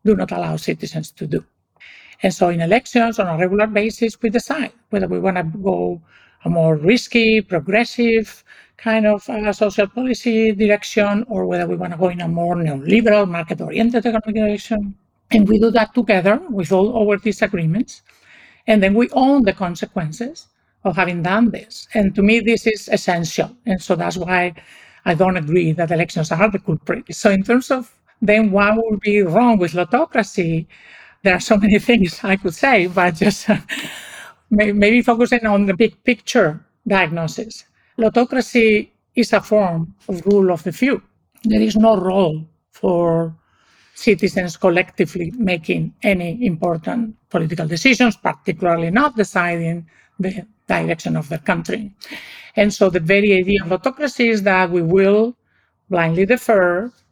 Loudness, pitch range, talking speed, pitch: -17 LUFS, 180-225 Hz, 160 wpm, 205 Hz